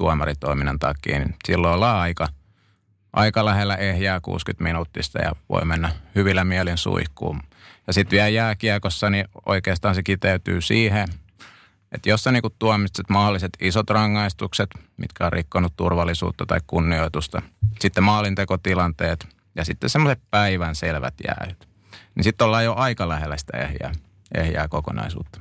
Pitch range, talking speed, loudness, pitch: 85-105 Hz, 135 wpm, -22 LUFS, 95 Hz